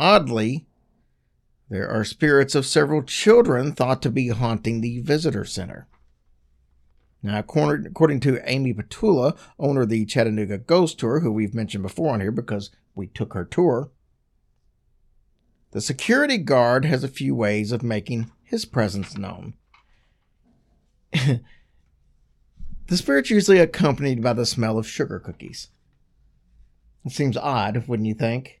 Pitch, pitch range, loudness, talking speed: 120 Hz, 105-145 Hz, -22 LUFS, 135 wpm